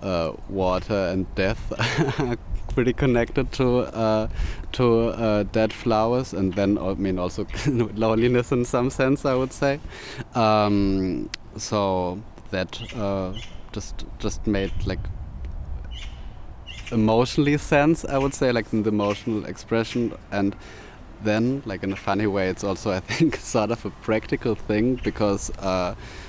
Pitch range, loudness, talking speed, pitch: 95-120 Hz, -24 LUFS, 140 wpm, 105 Hz